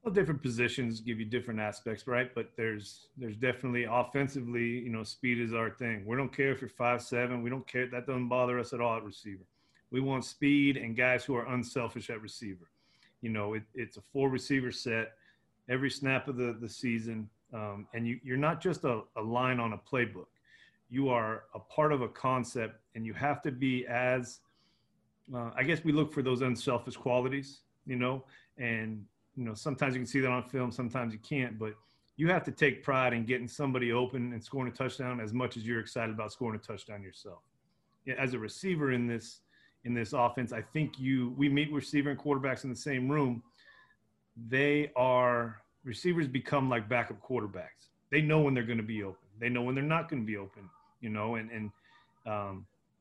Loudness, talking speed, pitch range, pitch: -33 LUFS, 205 wpm, 115-135 Hz, 125 Hz